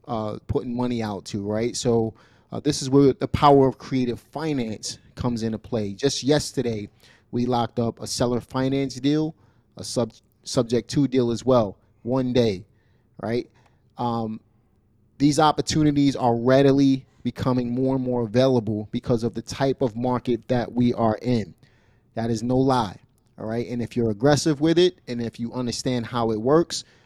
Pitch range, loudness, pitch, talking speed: 115-130 Hz, -23 LUFS, 120 Hz, 170 wpm